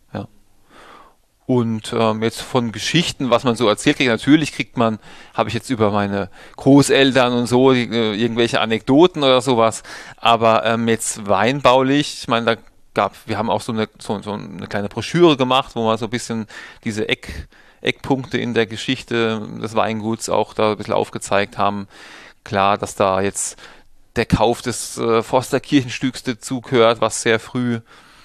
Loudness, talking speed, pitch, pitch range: -18 LUFS, 170 wpm, 115 Hz, 110-130 Hz